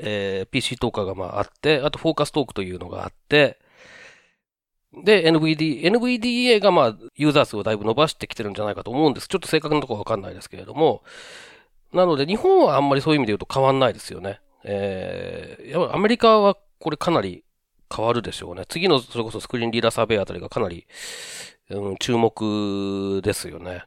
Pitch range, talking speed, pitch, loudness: 100-160 Hz, 440 characters per minute, 120 Hz, -21 LUFS